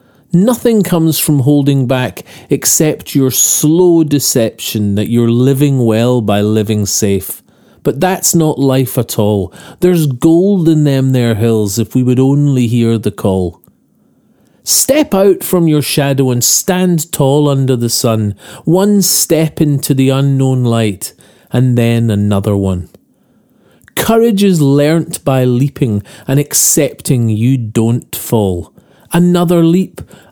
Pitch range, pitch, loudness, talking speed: 115-160 Hz, 135 Hz, -11 LUFS, 135 wpm